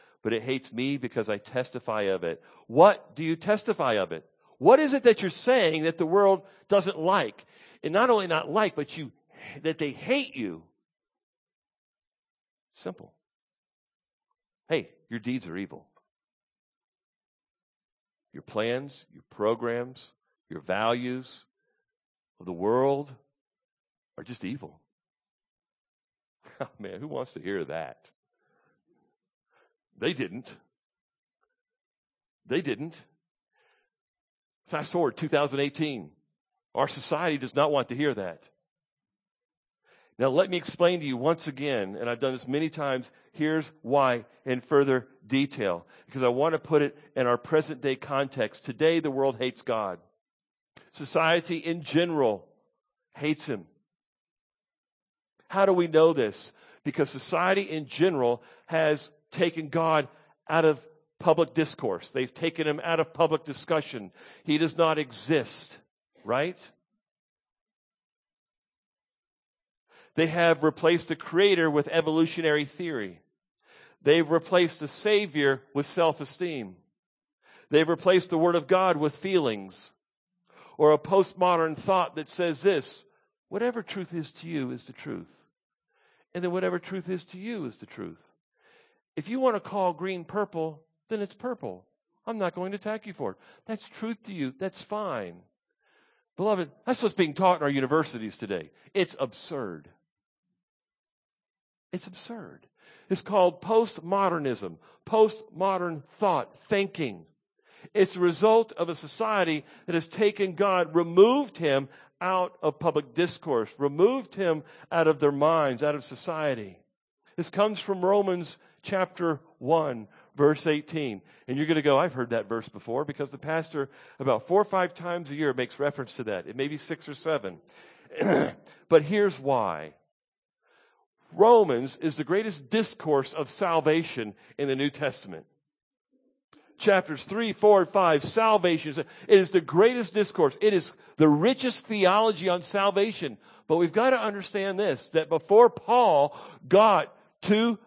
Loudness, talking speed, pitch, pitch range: -26 LUFS, 140 wpm, 165 Hz, 145-195 Hz